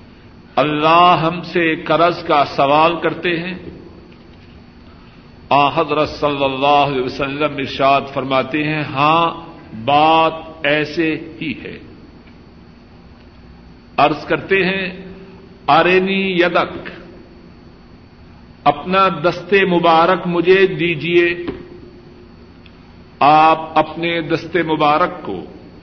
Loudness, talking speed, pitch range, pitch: -15 LUFS, 85 wpm, 130-170 Hz, 155 Hz